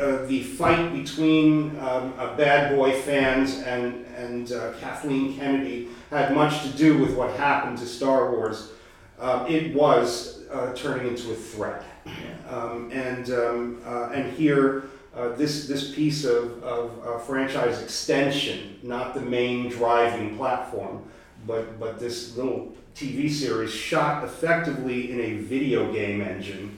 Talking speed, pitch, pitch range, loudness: 145 wpm, 125 Hz, 120-140 Hz, -25 LUFS